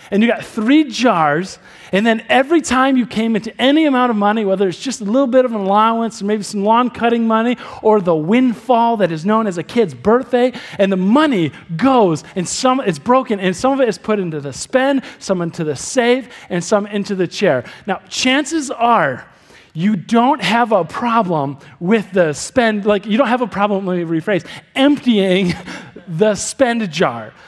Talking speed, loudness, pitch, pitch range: 200 wpm, -16 LUFS, 215 Hz, 190-250 Hz